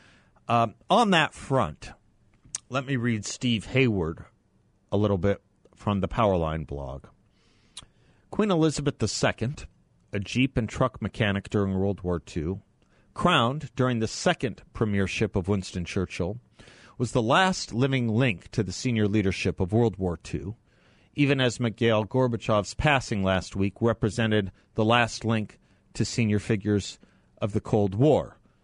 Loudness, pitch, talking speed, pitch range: -26 LUFS, 110 Hz, 140 wpm, 100-125 Hz